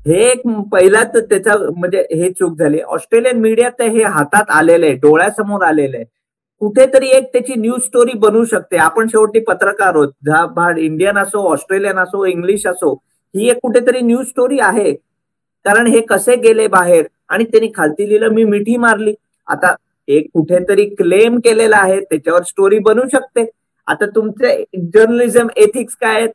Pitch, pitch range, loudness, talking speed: 220 Hz, 185-240 Hz, -12 LUFS, 160 wpm